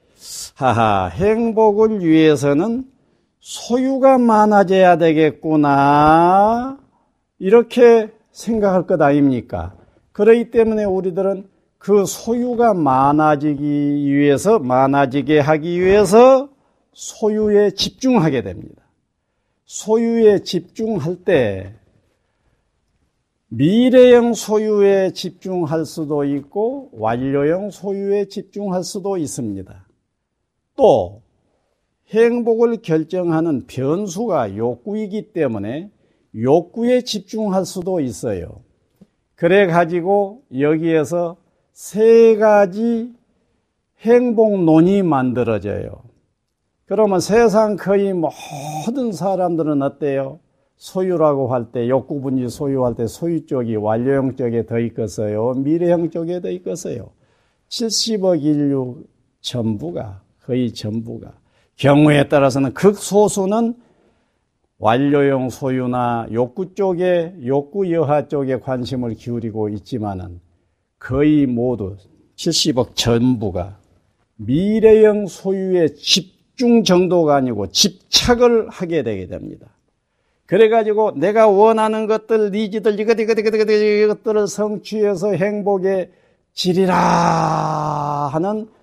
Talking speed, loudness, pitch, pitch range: 225 characters per minute, -16 LUFS, 170 Hz, 135-210 Hz